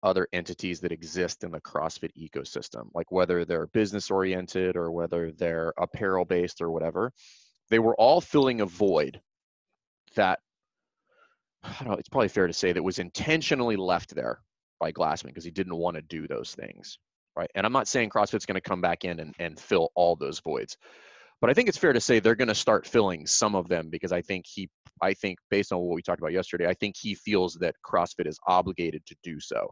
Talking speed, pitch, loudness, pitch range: 215 wpm, 90 Hz, -27 LUFS, 85-100 Hz